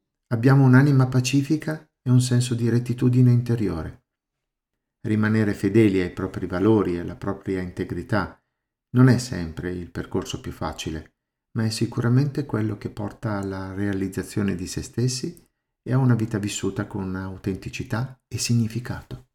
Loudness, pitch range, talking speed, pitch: -23 LUFS, 95-125 Hz, 140 wpm, 110 Hz